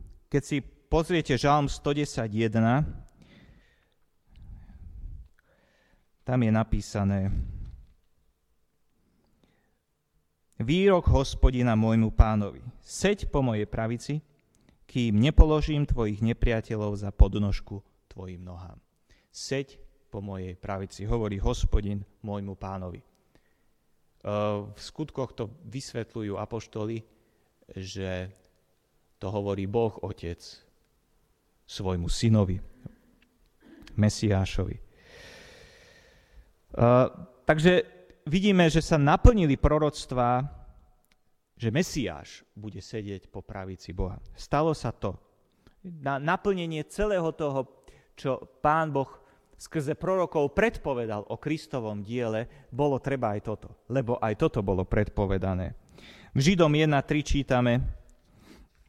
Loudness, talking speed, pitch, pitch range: -27 LUFS, 90 wpm, 110 Hz, 100-140 Hz